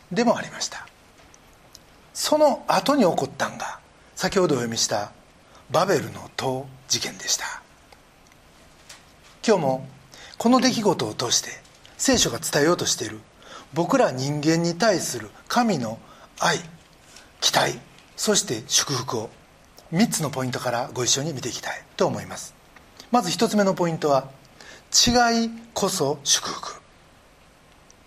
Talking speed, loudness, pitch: 230 characters per minute, -23 LUFS, 165 Hz